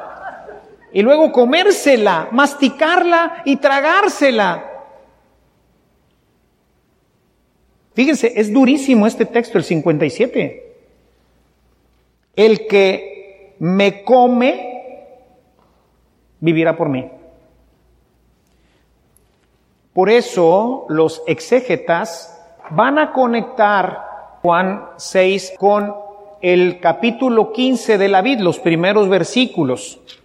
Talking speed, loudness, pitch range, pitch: 75 wpm, -15 LUFS, 175-255 Hz, 210 Hz